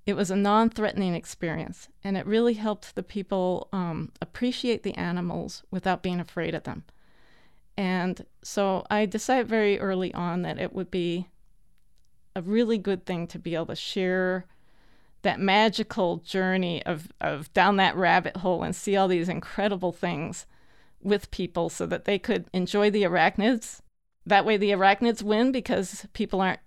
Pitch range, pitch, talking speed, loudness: 180-210 Hz, 190 Hz, 165 wpm, -26 LUFS